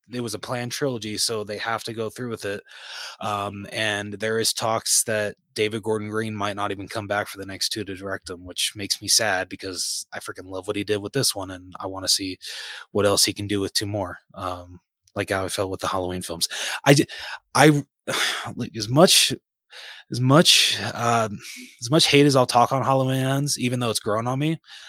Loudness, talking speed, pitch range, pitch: -22 LUFS, 220 wpm, 100-125 Hz, 105 Hz